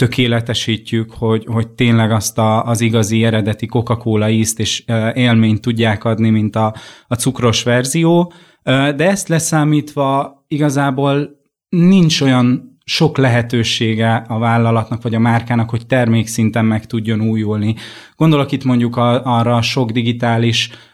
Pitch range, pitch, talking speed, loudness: 115-130 Hz, 120 Hz, 130 wpm, -15 LUFS